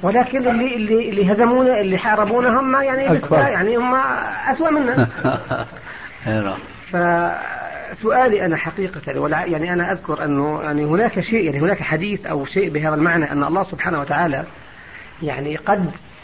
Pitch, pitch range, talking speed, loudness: 190 Hz, 155-240 Hz, 130 wpm, -19 LUFS